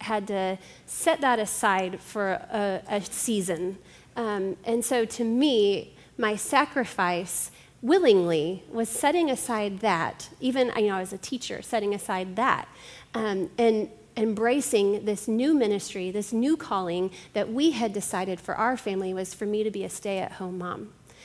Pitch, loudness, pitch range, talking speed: 210 Hz, -26 LUFS, 190-235 Hz, 160 wpm